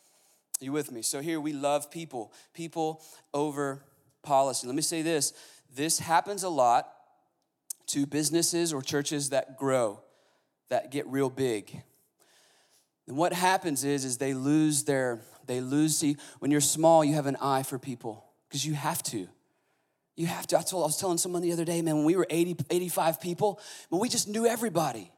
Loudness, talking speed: -29 LUFS, 185 wpm